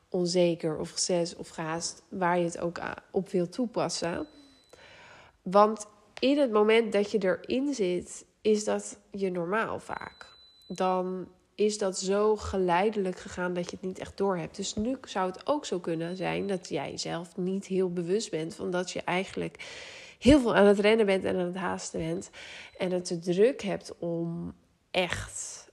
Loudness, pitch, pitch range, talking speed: -29 LUFS, 190 Hz, 175-215 Hz, 175 wpm